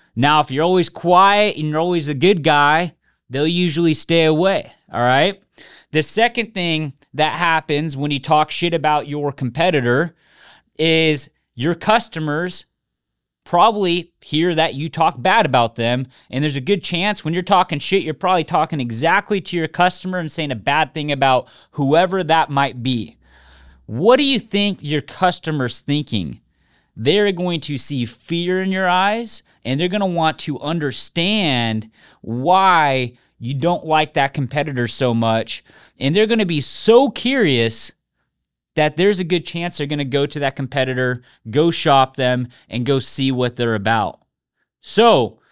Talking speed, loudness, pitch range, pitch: 165 wpm, -18 LUFS, 130-180 Hz, 155 Hz